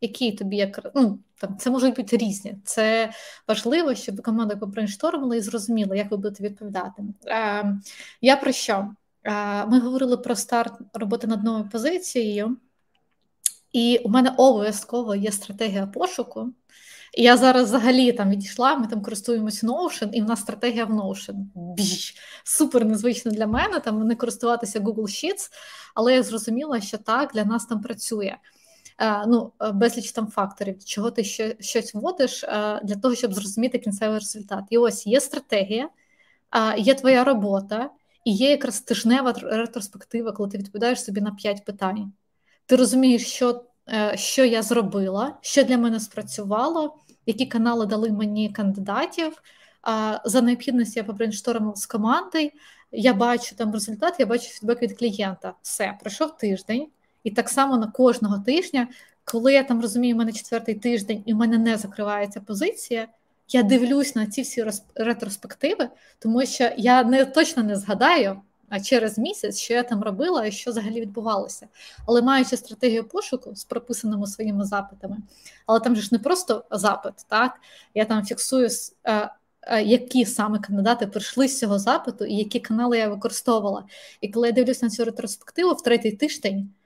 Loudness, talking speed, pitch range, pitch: -23 LUFS, 155 wpm, 210-250 Hz, 230 Hz